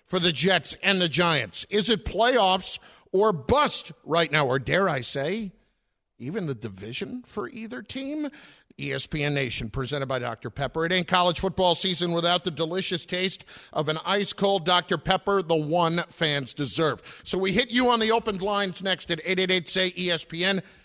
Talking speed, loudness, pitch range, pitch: 180 wpm, -25 LUFS, 155-195 Hz, 180 Hz